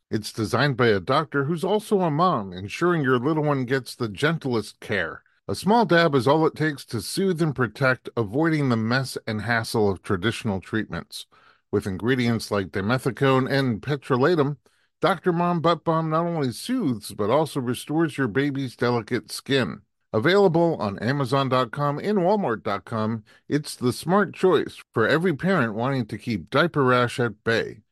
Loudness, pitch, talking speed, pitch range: -23 LUFS, 135 Hz, 160 wpm, 115-160 Hz